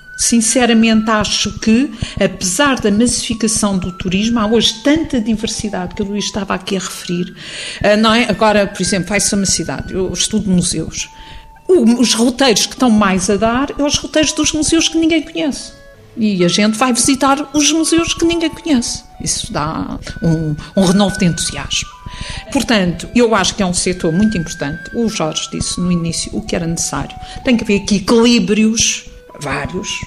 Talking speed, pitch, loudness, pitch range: 180 wpm, 215 Hz, -14 LUFS, 185-245 Hz